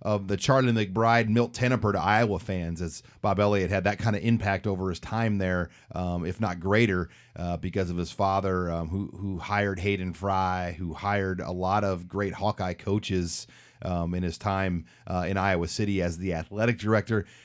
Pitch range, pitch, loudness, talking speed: 90-105 Hz, 95 Hz, -27 LUFS, 195 wpm